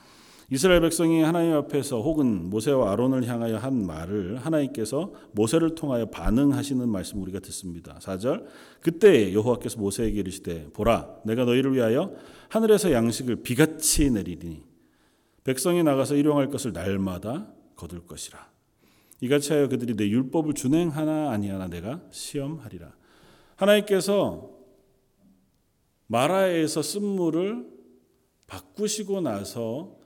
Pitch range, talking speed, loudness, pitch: 105-155 Hz, 310 characters per minute, -25 LUFS, 130 Hz